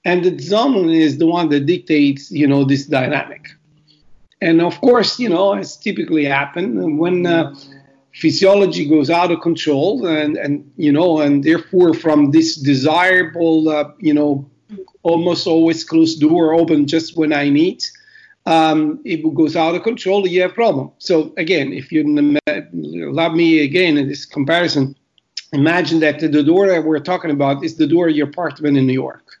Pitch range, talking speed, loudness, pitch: 150-180 Hz, 175 wpm, -15 LUFS, 160 Hz